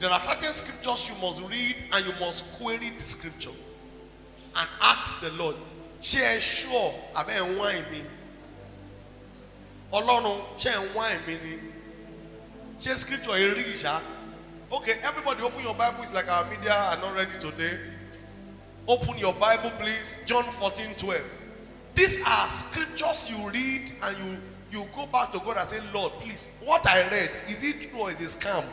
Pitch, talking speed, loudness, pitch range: 210 Hz, 145 wpm, -26 LUFS, 185-245 Hz